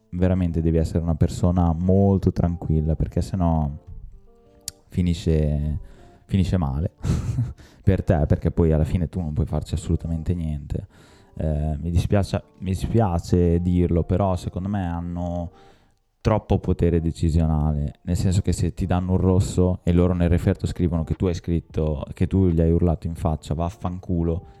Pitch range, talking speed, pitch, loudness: 80-95 Hz, 150 wpm, 90 Hz, -23 LUFS